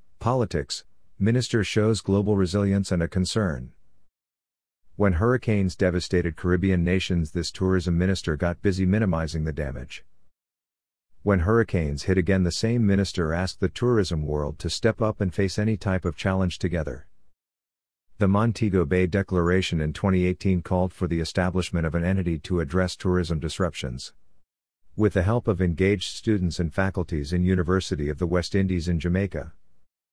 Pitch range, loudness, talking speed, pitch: 85-100 Hz, -25 LUFS, 150 wpm, 90 Hz